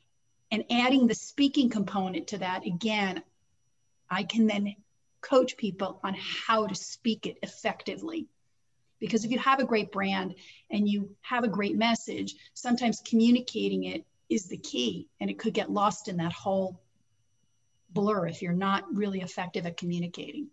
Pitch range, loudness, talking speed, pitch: 175-225 Hz, -29 LUFS, 160 wpm, 200 Hz